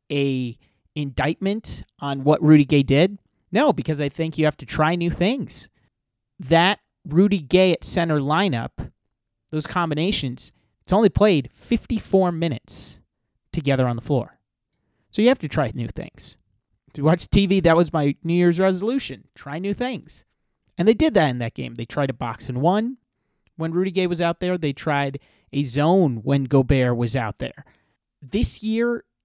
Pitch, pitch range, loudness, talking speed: 155 Hz, 135-185 Hz, -21 LUFS, 170 wpm